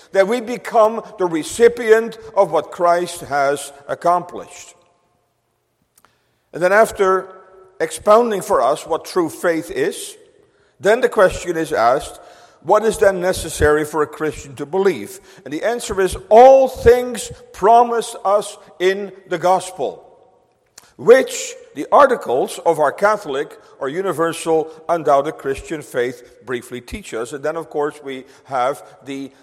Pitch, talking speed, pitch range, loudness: 185 Hz, 135 wpm, 155-220 Hz, -17 LUFS